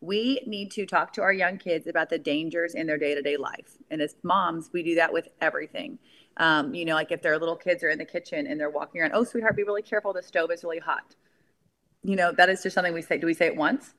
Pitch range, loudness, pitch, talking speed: 165-210 Hz, -26 LUFS, 175 Hz, 275 wpm